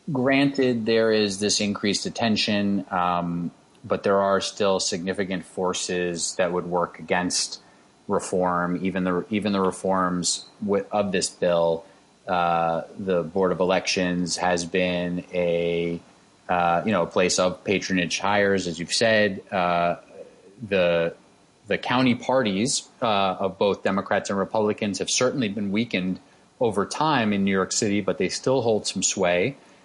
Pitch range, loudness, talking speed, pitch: 90-100 Hz, -24 LUFS, 145 wpm, 95 Hz